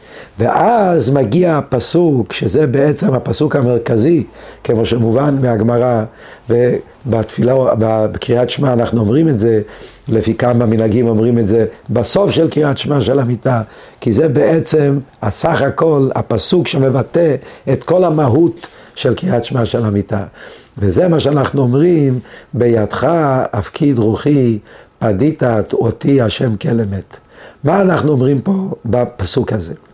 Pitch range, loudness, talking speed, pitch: 115-150 Hz, -14 LUFS, 120 wpm, 130 Hz